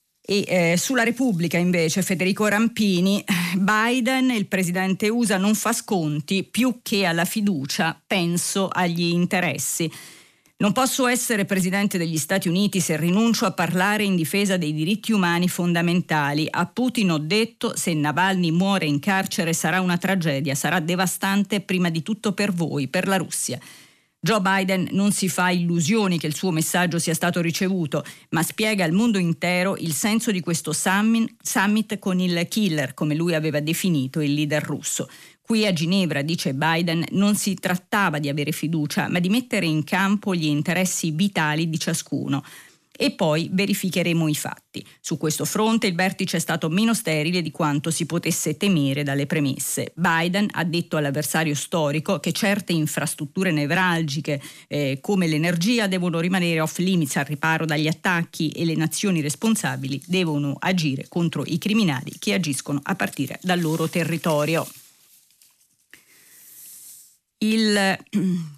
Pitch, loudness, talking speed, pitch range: 175 Hz, -22 LUFS, 150 wpm, 160-195 Hz